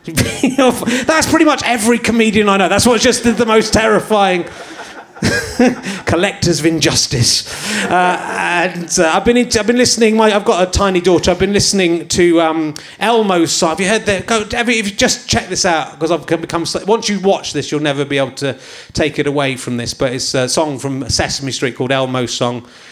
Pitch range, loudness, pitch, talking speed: 145-225 Hz, -14 LUFS, 180 Hz, 205 wpm